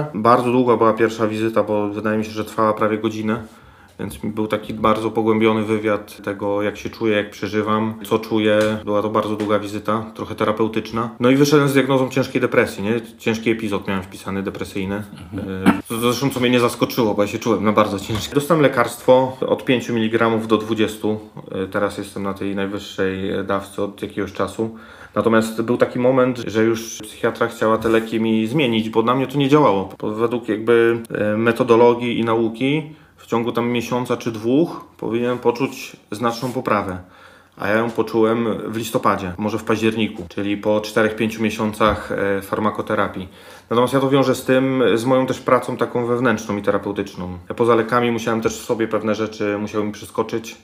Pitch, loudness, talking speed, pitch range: 110 Hz, -19 LUFS, 175 wpm, 105-120 Hz